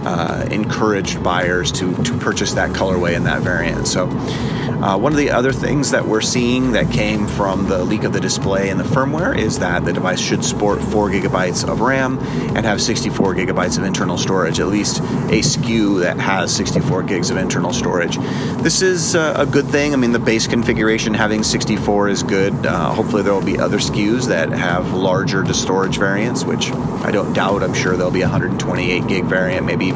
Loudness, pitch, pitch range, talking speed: -17 LUFS, 115 Hz, 100-135 Hz, 210 wpm